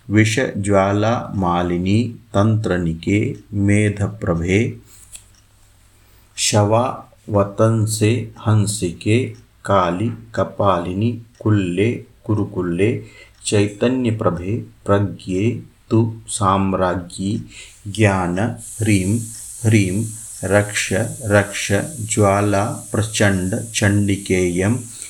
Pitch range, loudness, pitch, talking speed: 100-110 Hz, -19 LUFS, 105 Hz, 50 wpm